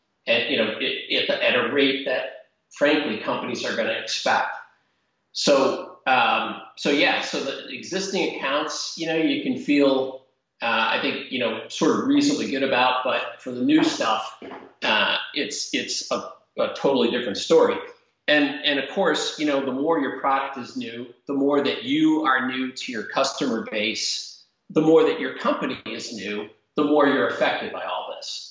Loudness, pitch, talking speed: -23 LUFS, 145 Hz, 185 wpm